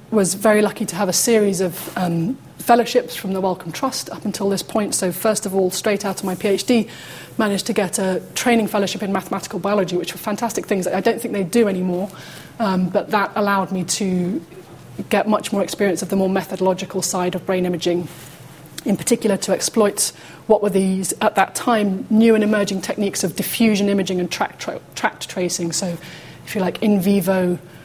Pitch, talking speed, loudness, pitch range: 195 Hz, 200 wpm, -20 LUFS, 180-210 Hz